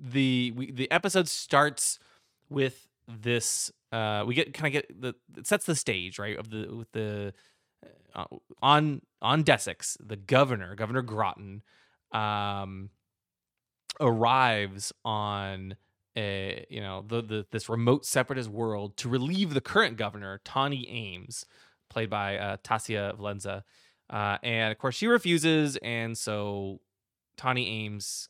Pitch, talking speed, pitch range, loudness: 115 Hz, 140 wpm, 100-130 Hz, -29 LUFS